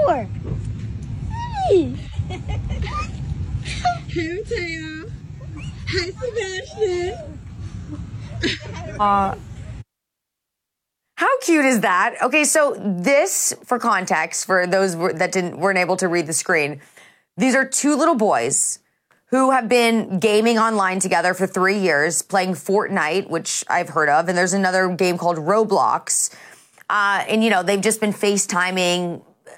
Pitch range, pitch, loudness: 165-225 Hz, 190 Hz, -19 LUFS